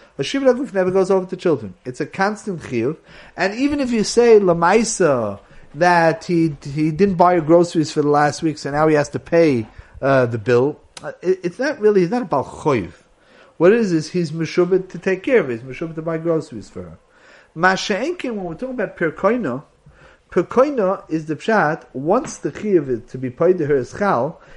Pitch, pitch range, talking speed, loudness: 170 Hz, 150-195 Hz, 205 wpm, -18 LUFS